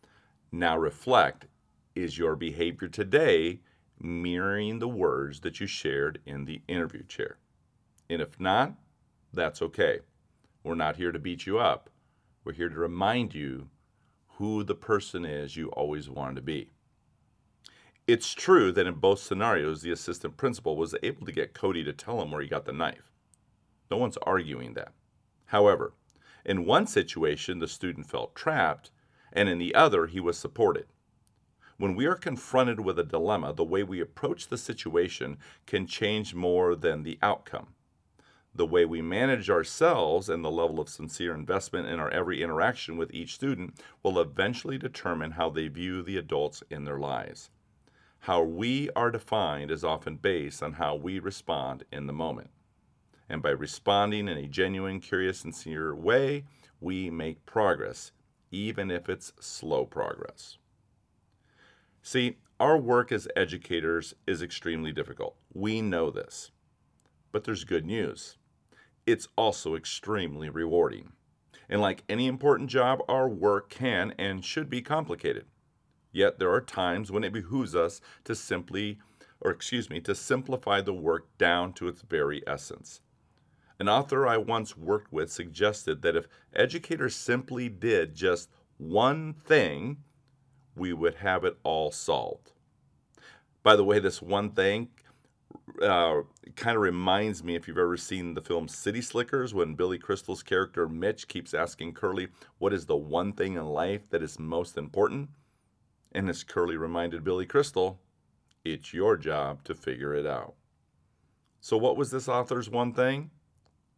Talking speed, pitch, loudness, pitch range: 155 wpm, 95 Hz, -29 LUFS, 85-120 Hz